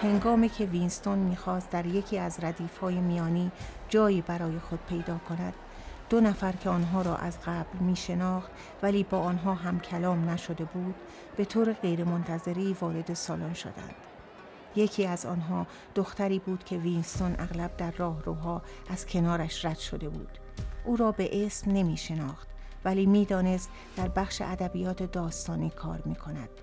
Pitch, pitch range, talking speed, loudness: 180 Hz, 170-190 Hz, 145 wpm, -31 LUFS